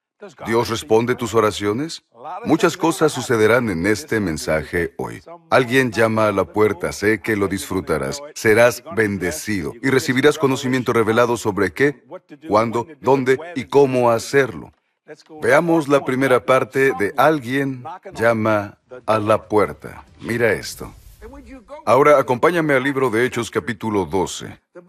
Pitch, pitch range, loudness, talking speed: 125 Hz, 110-140 Hz, -18 LUFS, 130 wpm